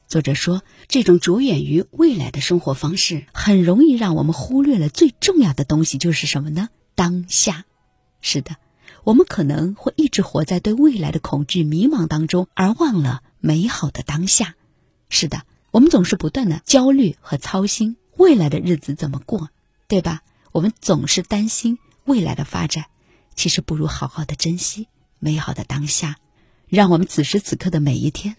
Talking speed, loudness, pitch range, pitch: 265 characters per minute, -18 LUFS, 150-210 Hz, 175 Hz